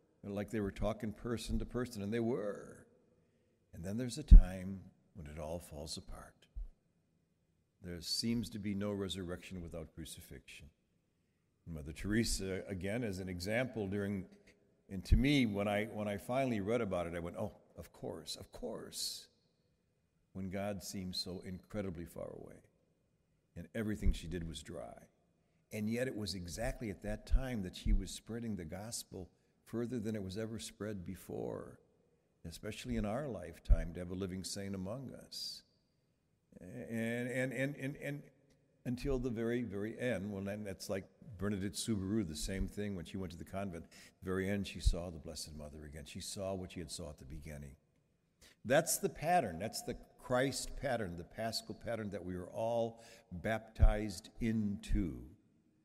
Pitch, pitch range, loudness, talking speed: 100 Hz, 90-115 Hz, -39 LUFS, 170 wpm